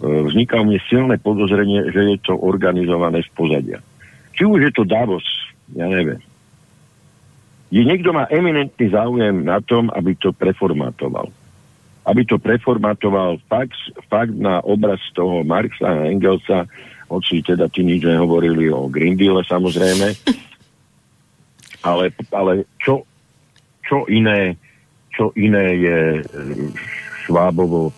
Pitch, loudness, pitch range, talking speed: 100 Hz, -17 LUFS, 90-115 Hz, 120 wpm